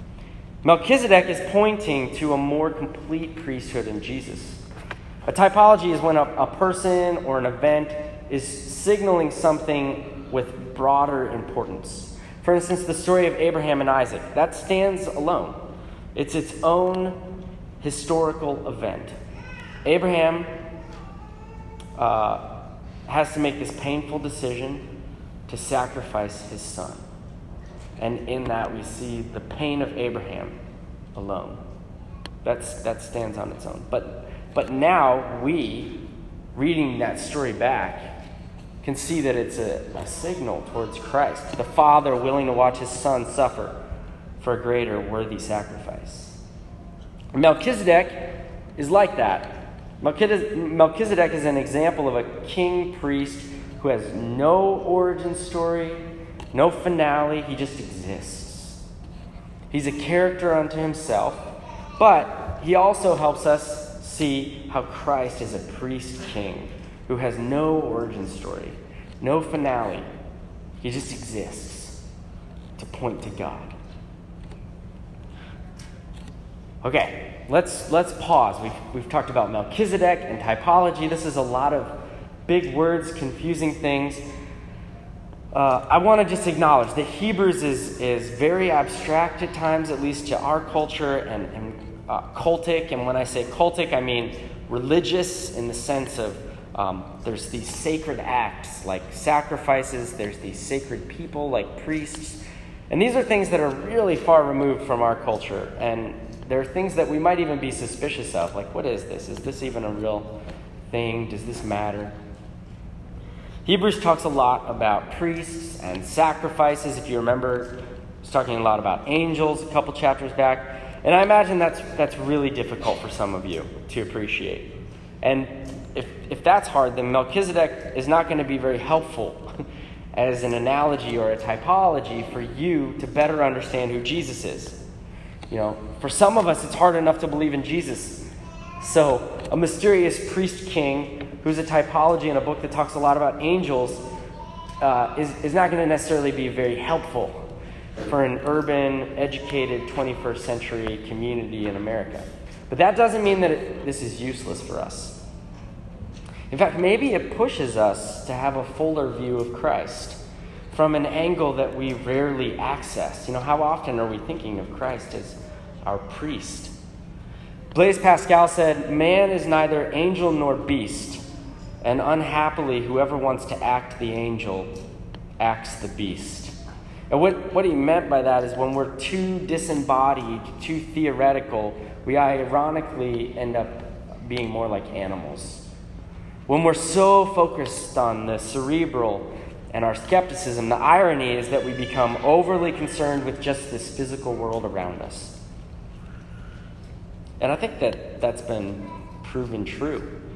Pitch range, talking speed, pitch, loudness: 115-160 Hz, 145 wpm, 135 Hz, -23 LUFS